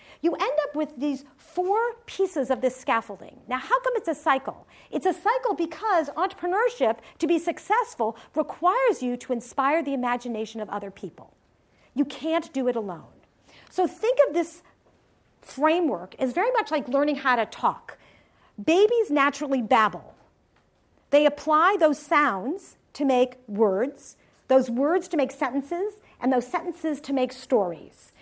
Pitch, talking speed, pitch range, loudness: 295 Hz, 155 wpm, 255-345 Hz, -25 LUFS